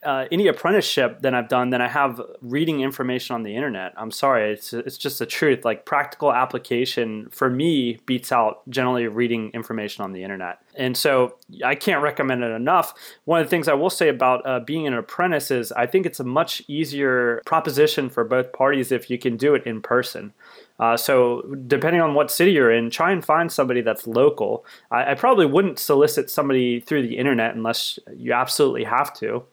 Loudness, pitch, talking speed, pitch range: -21 LUFS, 125 Hz, 200 wpm, 120-145 Hz